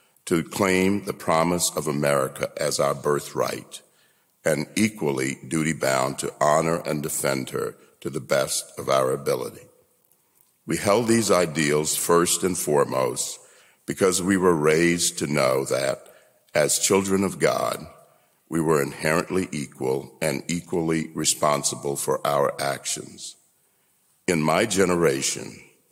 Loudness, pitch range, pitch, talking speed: -23 LUFS, 75-95 Hz, 80 Hz, 125 wpm